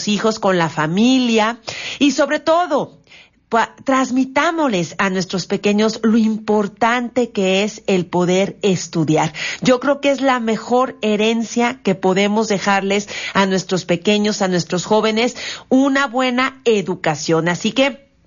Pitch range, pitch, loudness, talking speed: 190-255 Hz, 215 Hz, -17 LUFS, 130 wpm